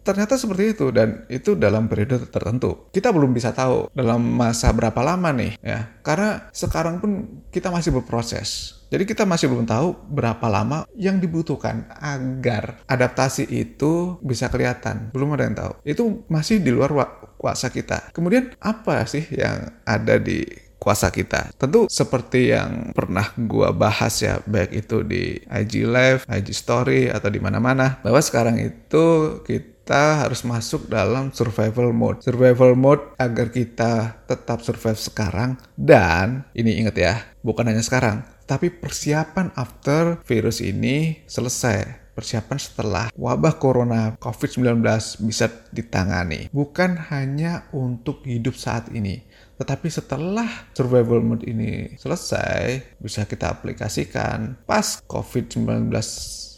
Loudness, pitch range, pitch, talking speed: -21 LUFS, 110-145 Hz, 125 Hz, 135 wpm